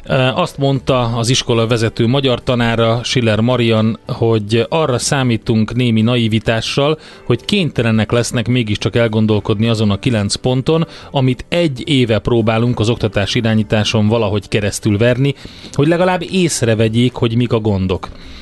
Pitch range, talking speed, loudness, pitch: 110-130 Hz, 130 wpm, -15 LUFS, 115 Hz